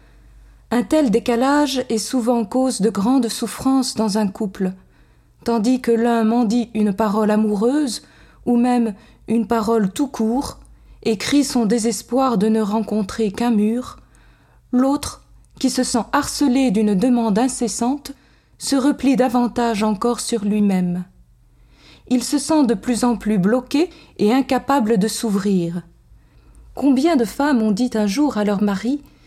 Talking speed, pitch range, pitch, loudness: 145 wpm, 220-260 Hz, 235 Hz, -19 LUFS